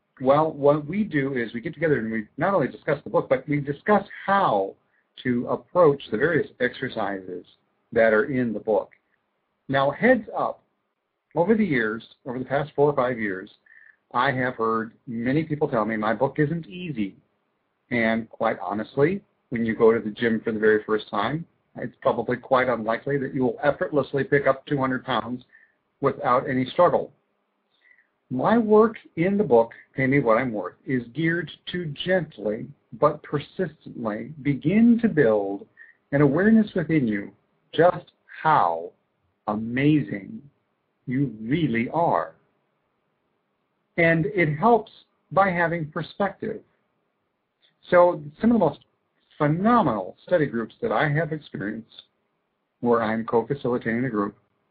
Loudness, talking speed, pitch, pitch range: -24 LUFS, 145 wpm, 140 Hz, 115-170 Hz